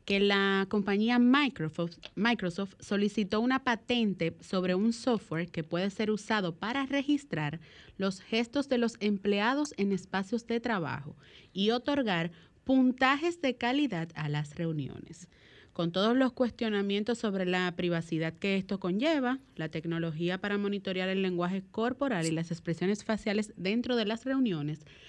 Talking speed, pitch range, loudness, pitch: 140 wpm, 175-235 Hz, -31 LUFS, 200 Hz